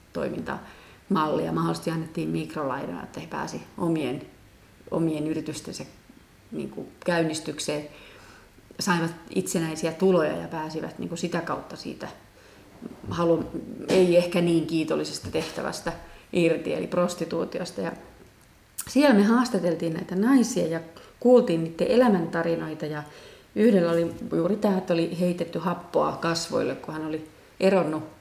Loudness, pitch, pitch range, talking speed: -26 LUFS, 165 Hz, 155-180 Hz, 115 wpm